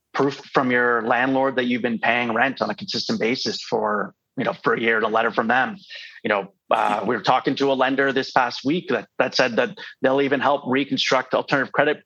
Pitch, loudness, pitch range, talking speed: 130 Hz, -21 LUFS, 125-135 Hz, 225 wpm